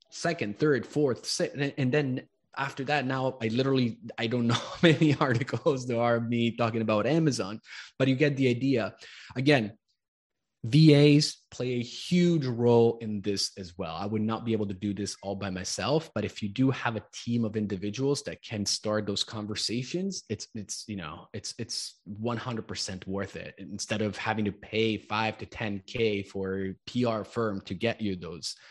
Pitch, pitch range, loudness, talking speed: 115 Hz, 105-130 Hz, -29 LUFS, 185 wpm